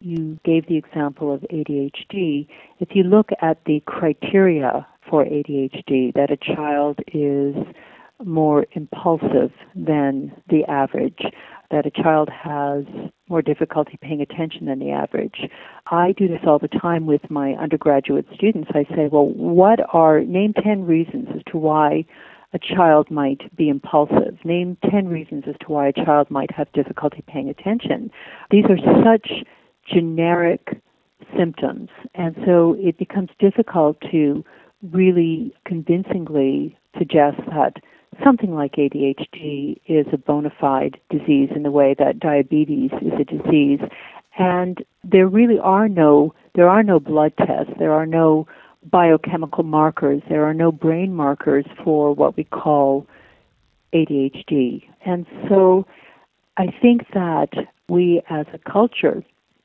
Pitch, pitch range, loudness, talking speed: 155 Hz, 145-180 Hz, -18 LUFS, 140 wpm